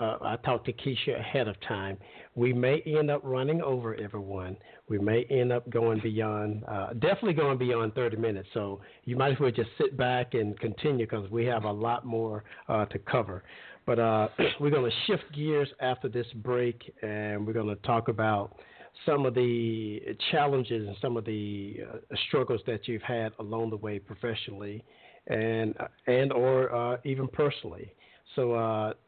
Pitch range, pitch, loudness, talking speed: 110-125 Hz, 115 Hz, -30 LUFS, 175 wpm